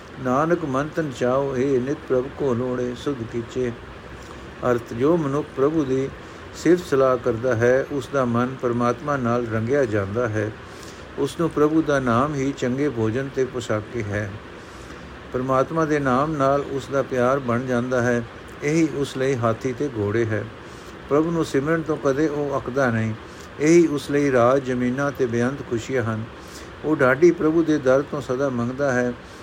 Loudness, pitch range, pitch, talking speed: -22 LUFS, 120-145 Hz, 130 Hz, 165 wpm